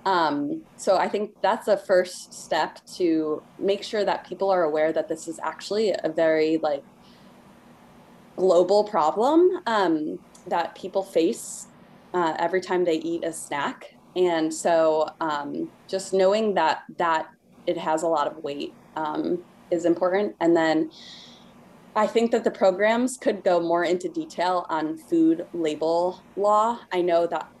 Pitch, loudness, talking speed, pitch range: 185 Hz, -24 LUFS, 150 wpm, 165-215 Hz